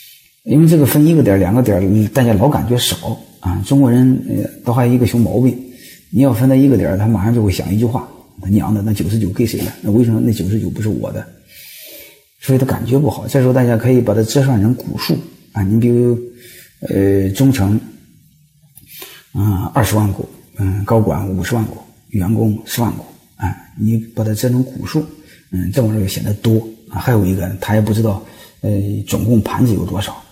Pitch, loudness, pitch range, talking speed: 115 Hz, -15 LUFS, 105-125 Hz, 290 characters per minute